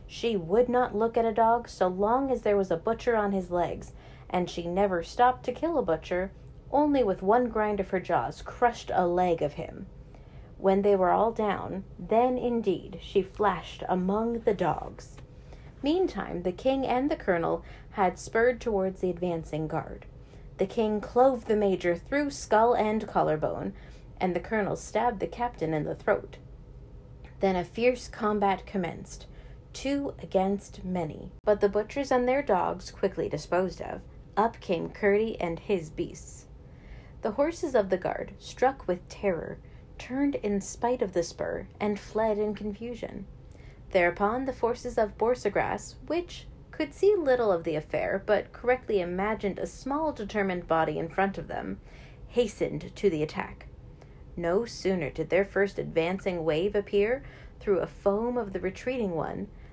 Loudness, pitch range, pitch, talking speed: -28 LUFS, 180-240 Hz, 205 Hz, 165 wpm